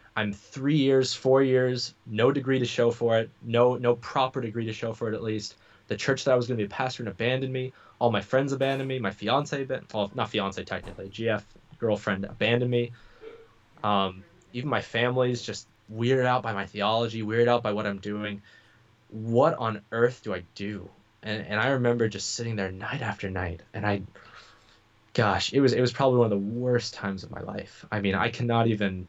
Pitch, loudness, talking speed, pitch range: 115 Hz, -27 LUFS, 210 wpm, 105-125 Hz